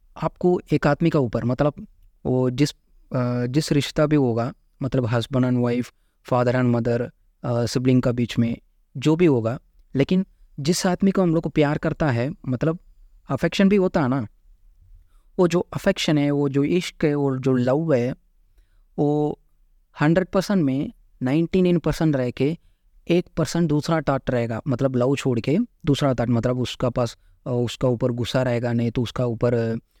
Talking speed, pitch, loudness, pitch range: 170 wpm, 135 Hz, -22 LUFS, 120-155 Hz